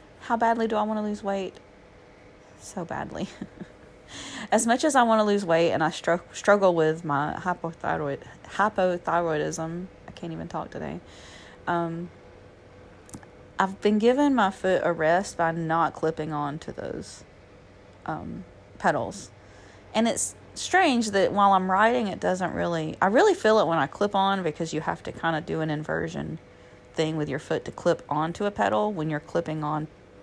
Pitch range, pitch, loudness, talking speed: 150-200 Hz, 165 Hz, -25 LUFS, 175 wpm